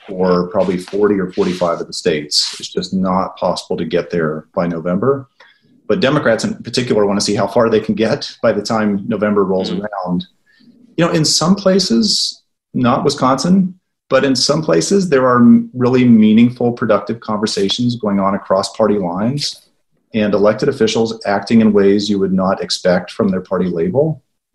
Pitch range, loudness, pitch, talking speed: 100-135 Hz, -15 LUFS, 110 Hz, 175 wpm